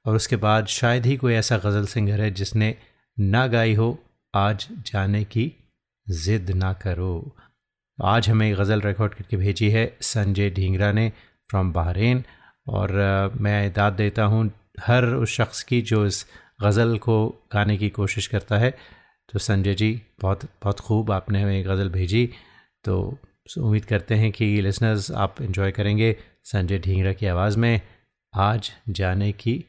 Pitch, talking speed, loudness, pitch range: 105 Hz, 155 wpm, -23 LUFS, 100-115 Hz